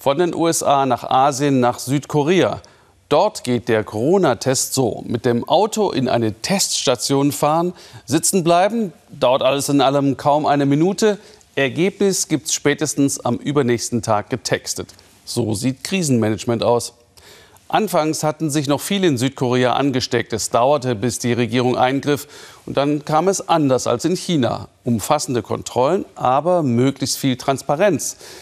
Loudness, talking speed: -18 LUFS, 145 wpm